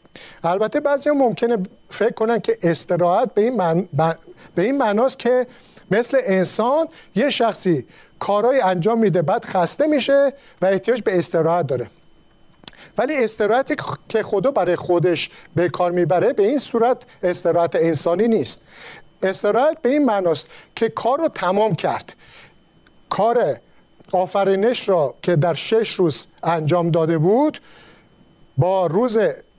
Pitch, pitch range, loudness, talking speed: 200 Hz, 175-245 Hz, -19 LUFS, 135 wpm